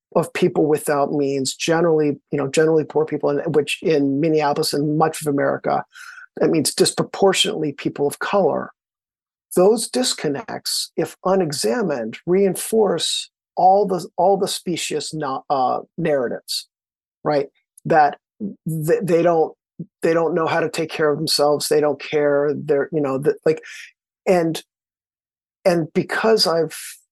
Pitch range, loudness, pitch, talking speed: 145-190 Hz, -20 LUFS, 160 Hz, 140 wpm